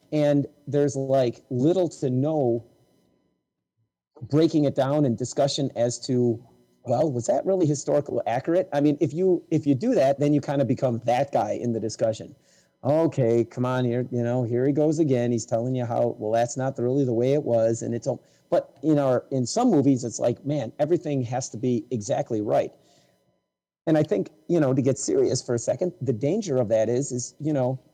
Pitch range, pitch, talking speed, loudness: 120-145 Hz, 135 Hz, 205 wpm, -24 LUFS